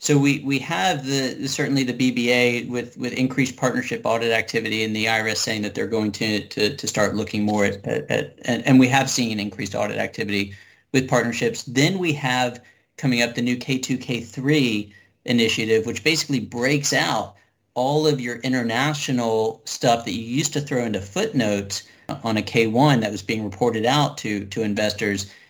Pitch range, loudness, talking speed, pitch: 110-135 Hz, -22 LUFS, 180 wpm, 120 Hz